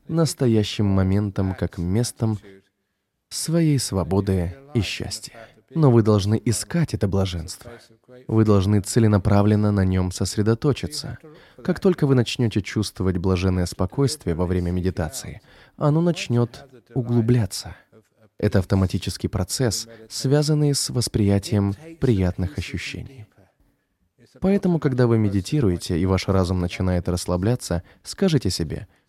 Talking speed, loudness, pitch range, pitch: 105 wpm, -22 LUFS, 95-125 Hz, 105 Hz